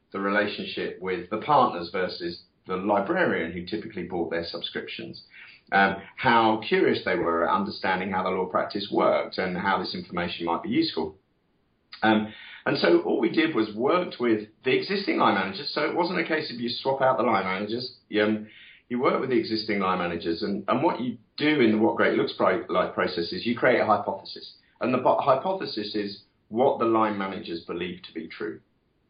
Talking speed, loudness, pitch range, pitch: 200 wpm, -26 LUFS, 100-125 Hz, 110 Hz